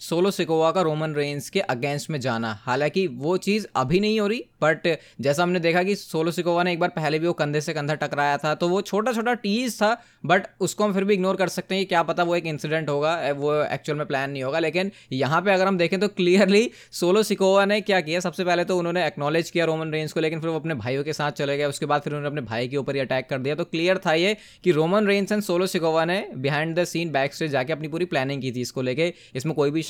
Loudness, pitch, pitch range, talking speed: -23 LUFS, 165 Hz, 145-185 Hz, 265 wpm